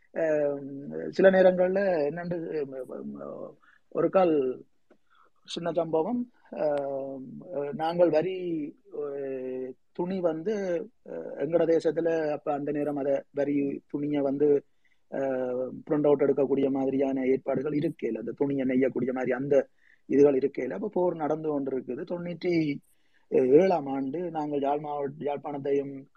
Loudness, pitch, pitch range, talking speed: -28 LUFS, 145 Hz, 135-170 Hz, 100 wpm